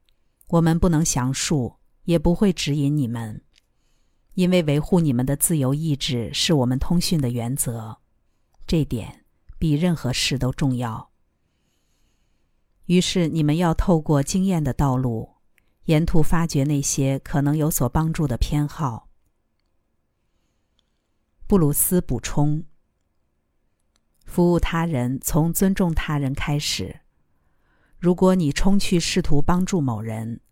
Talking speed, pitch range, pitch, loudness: 185 characters per minute, 115-165 Hz, 145 Hz, -22 LUFS